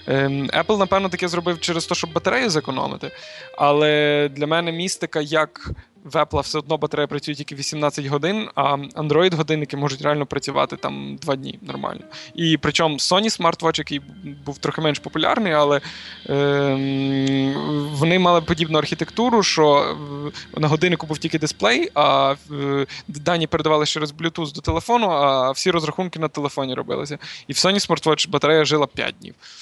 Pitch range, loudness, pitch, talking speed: 145-165 Hz, -20 LUFS, 155 Hz, 150 wpm